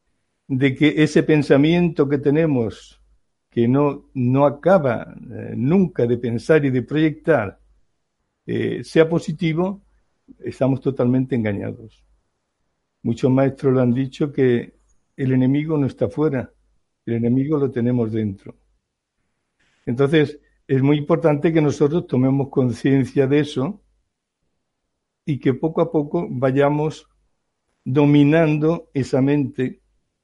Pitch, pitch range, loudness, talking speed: 140 Hz, 125-155 Hz, -19 LUFS, 115 wpm